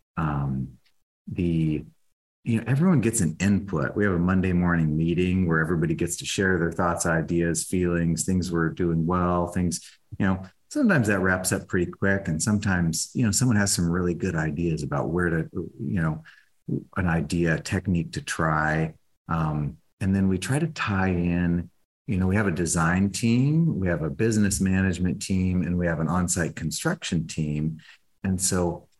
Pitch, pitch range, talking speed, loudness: 90 Hz, 80-95 Hz, 180 wpm, -25 LUFS